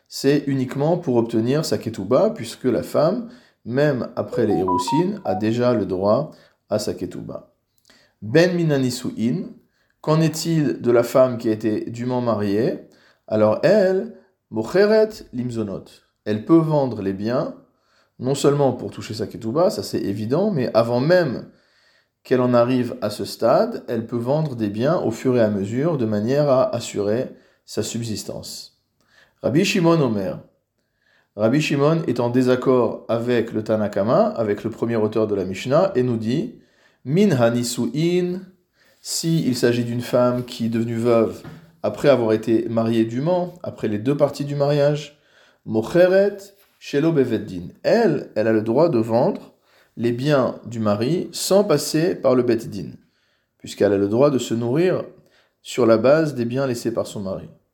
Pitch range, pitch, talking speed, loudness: 110-145 Hz, 125 Hz, 155 wpm, -20 LUFS